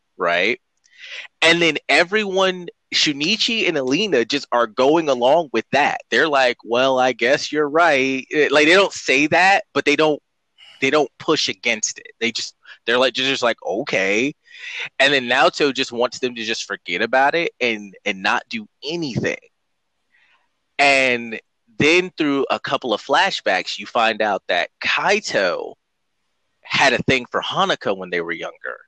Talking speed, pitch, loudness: 160 wpm, 150 Hz, -18 LUFS